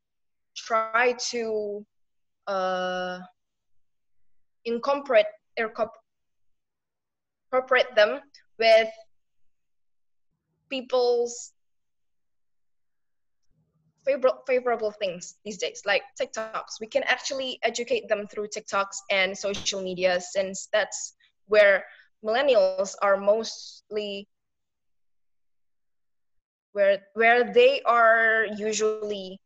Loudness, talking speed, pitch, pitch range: -25 LUFS, 70 wpm, 215 Hz, 185-240 Hz